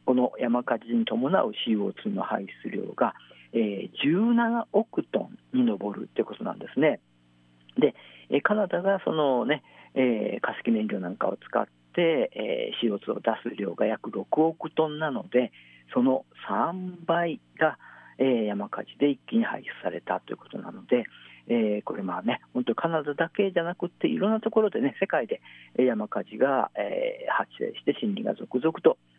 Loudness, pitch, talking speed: -27 LUFS, 165 Hz, 270 characters per minute